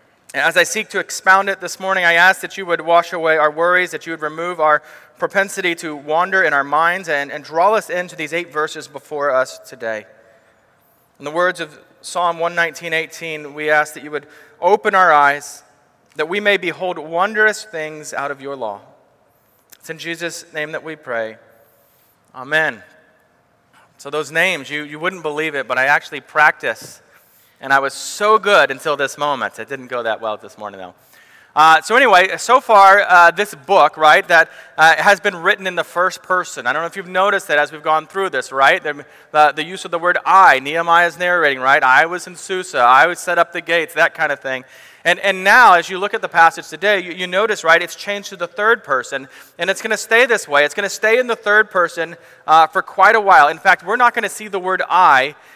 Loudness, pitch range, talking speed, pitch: -15 LUFS, 145-185 Hz, 225 wpm, 165 Hz